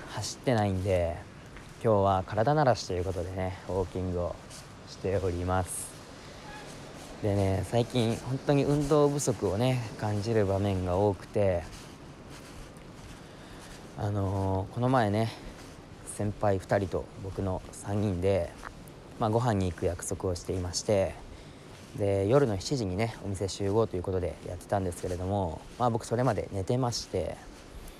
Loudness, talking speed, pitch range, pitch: -30 LUFS, 270 characters per minute, 95-120 Hz, 100 Hz